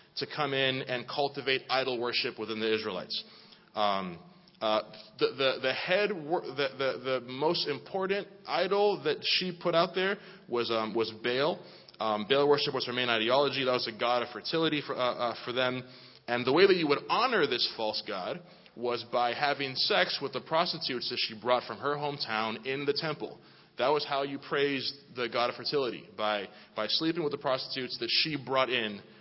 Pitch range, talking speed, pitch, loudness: 120-150 Hz, 195 wpm, 130 Hz, -30 LUFS